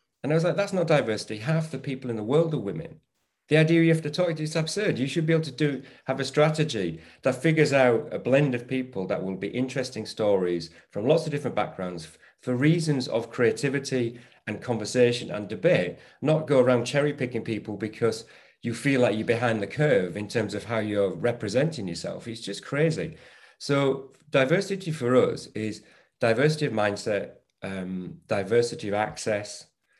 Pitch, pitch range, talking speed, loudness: 125 Hz, 110-150 Hz, 190 wpm, -26 LUFS